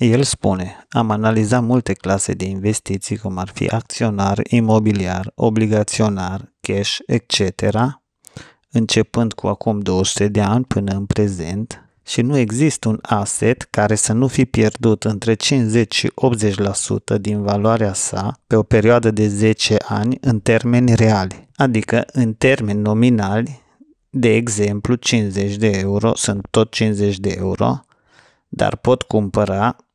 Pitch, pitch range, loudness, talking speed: 110 Hz, 100-120 Hz, -17 LUFS, 135 wpm